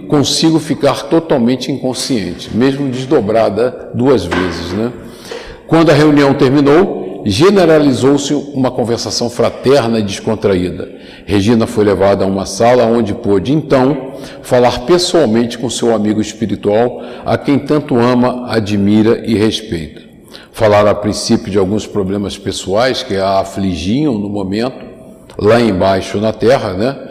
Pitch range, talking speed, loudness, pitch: 105-135 Hz, 130 wpm, -13 LUFS, 115 Hz